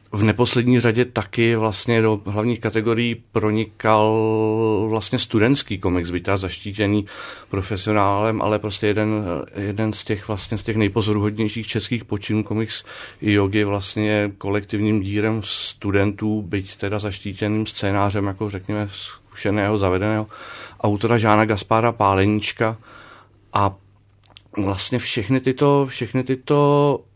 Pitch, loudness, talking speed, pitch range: 105 Hz, -21 LUFS, 115 wpm, 100-110 Hz